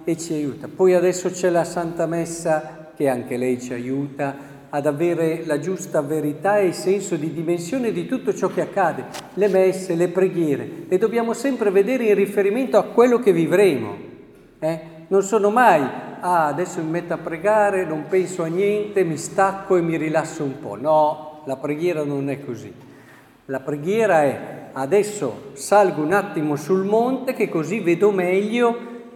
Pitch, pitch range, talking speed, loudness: 175 Hz, 155-200 Hz, 170 wpm, -21 LUFS